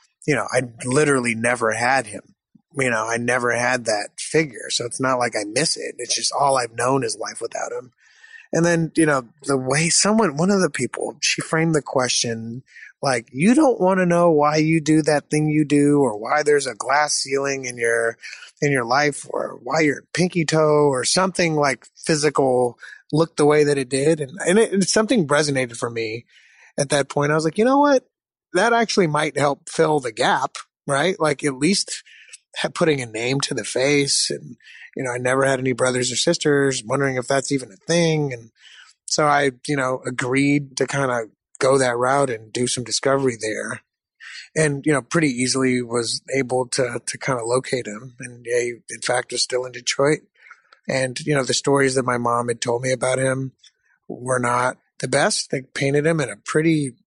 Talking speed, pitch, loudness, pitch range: 205 wpm, 140 Hz, -20 LUFS, 125-155 Hz